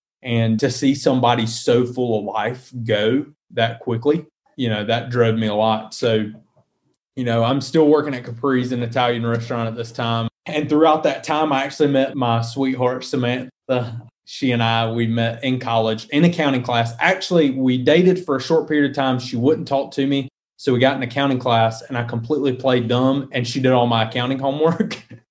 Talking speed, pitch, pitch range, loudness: 200 wpm, 125 Hz, 115-140 Hz, -19 LUFS